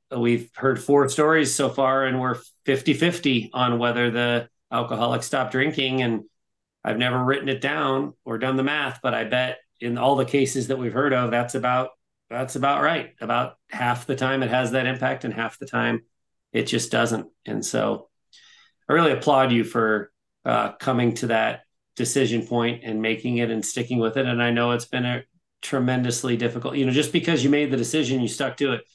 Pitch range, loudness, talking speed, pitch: 120-135 Hz, -23 LUFS, 200 wpm, 125 Hz